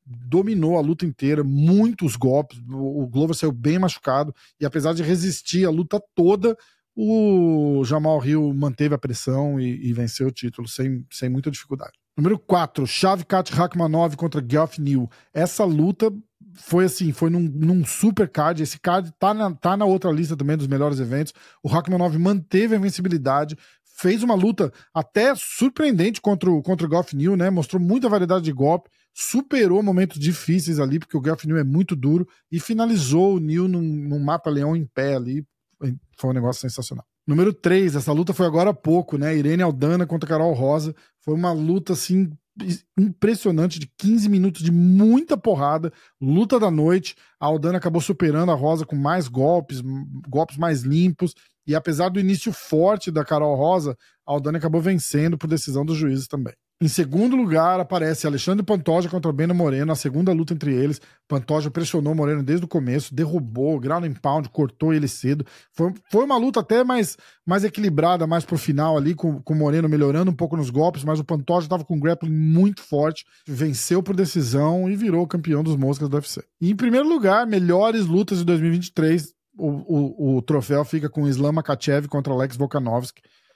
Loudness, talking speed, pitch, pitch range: -21 LUFS, 180 wpm, 165 Hz, 145-185 Hz